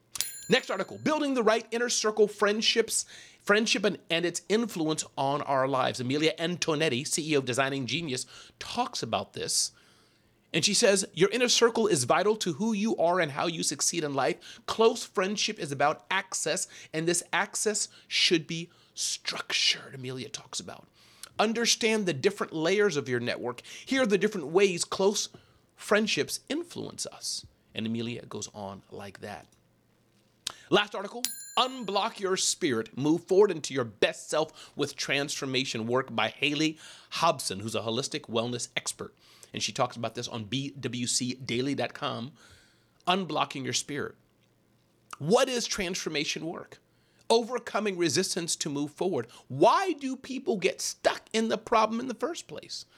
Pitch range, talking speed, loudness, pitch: 135-215 Hz, 150 wpm, -28 LUFS, 175 Hz